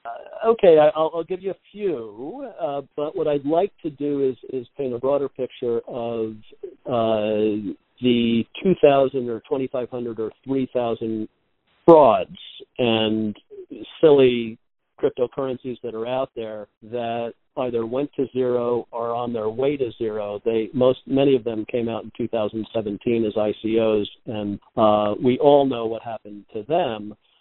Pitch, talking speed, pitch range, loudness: 120 Hz, 155 wpm, 110-140 Hz, -22 LUFS